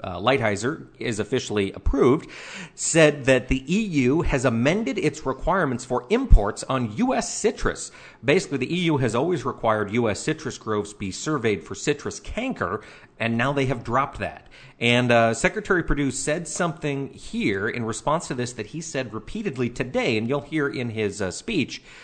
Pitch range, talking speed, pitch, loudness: 115-155 Hz, 165 wpm, 130 Hz, -24 LUFS